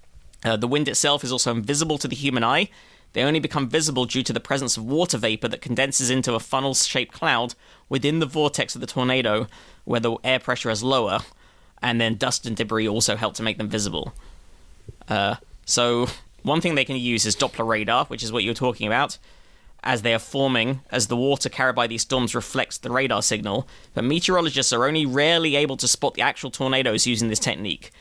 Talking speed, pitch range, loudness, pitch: 210 wpm, 115-135 Hz, -22 LUFS, 125 Hz